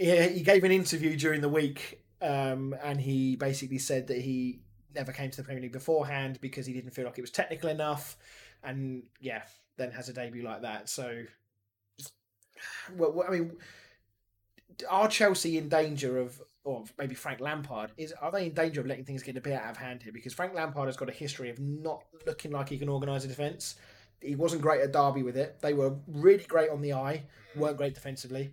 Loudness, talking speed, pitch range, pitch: -31 LUFS, 210 wpm, 125-155 Hz, 135 Hz